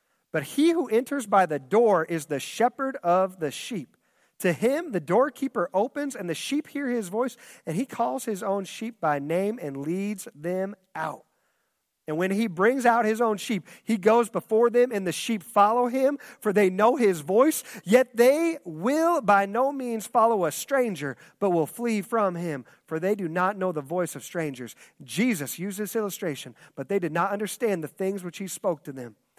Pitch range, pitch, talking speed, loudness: 175-235 Hz, 205 Hz, 200 wpm, -26 LUFS